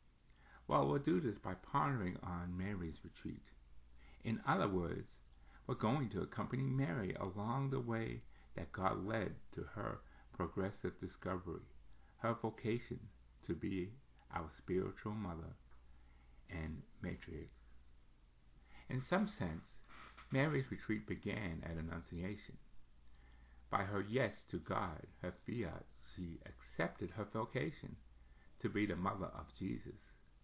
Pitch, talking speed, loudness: 85 Hz, 120 wpm, -43 LUFS